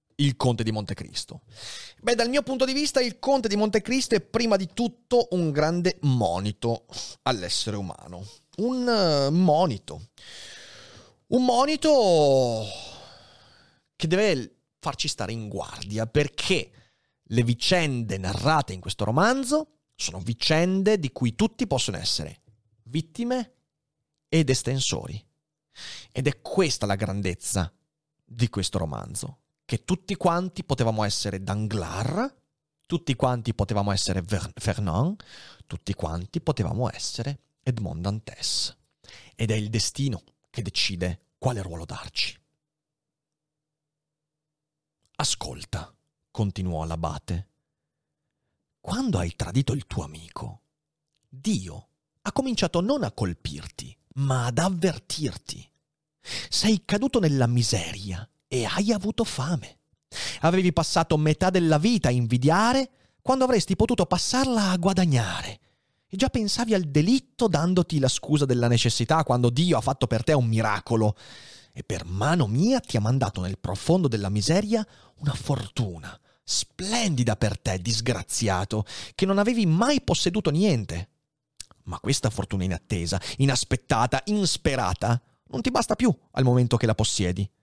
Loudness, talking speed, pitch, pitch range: -25 LUFS, 125 wpm, 135 Hz, 110-175 Hz